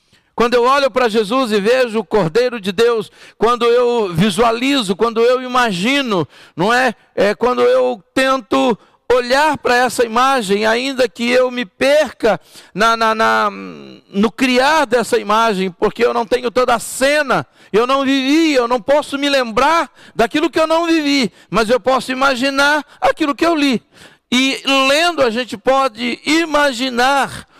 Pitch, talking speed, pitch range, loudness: 250 Hz, 160 wpm, 230-270 Hz, -15 LUFS